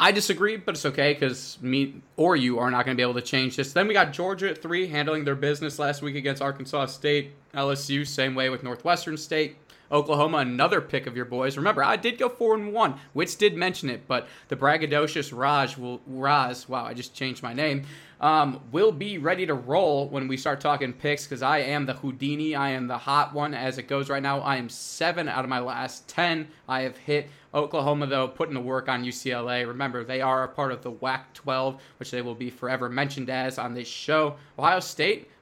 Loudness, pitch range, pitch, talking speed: -26 LUFS, 130-150 Hz, 140 Hz, 225 wpm